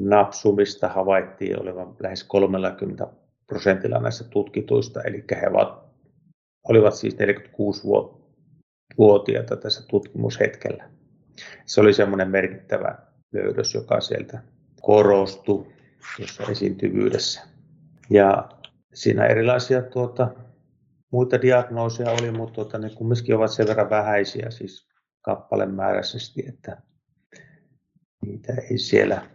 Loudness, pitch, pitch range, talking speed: -22 LUFS, 115 Hz, 100-130 Hz, 95 wpm